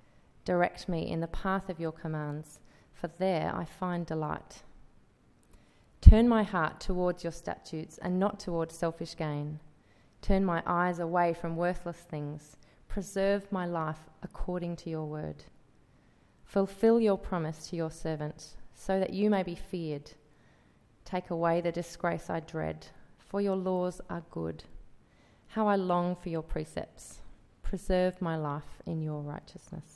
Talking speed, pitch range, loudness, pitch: 145 wpm, 155-185 Hz, -32 LUFS, 170 Hz